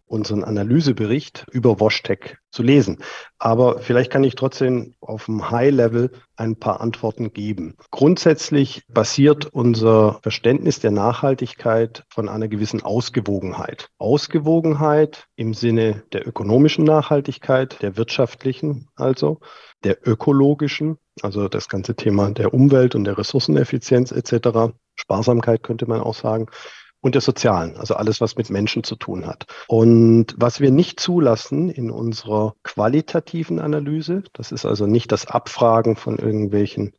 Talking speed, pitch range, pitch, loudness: 135 wpm, 110-140 Hz, 120 Hz, -19 LUFS